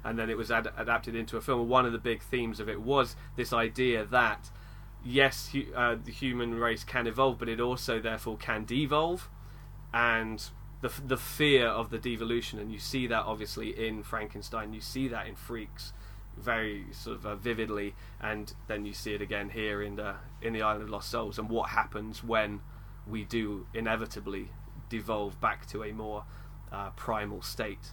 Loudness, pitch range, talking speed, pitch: -32 LUFS, 105-125 Hz, 190 wpm, 115 Hz